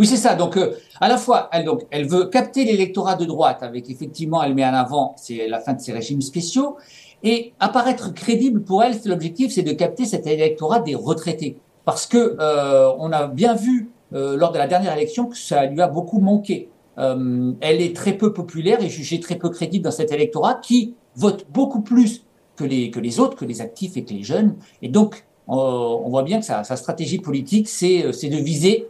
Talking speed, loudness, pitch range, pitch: 220 wpm, -20 LUFS, 145-225 Hz, 180 Hz